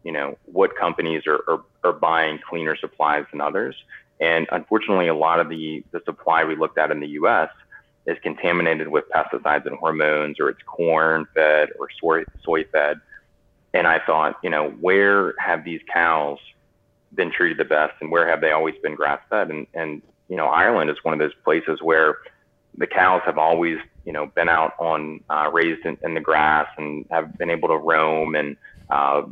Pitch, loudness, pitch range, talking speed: 80 Hz, -21 LUFS, 75-80 Hz, 195 wpm